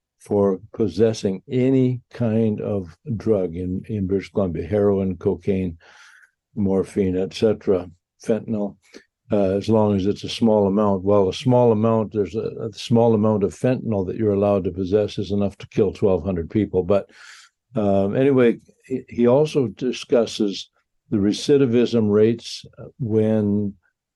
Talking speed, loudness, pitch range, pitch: 140 wpm, -21 LUFS, 100-115 Hz, 105 Hz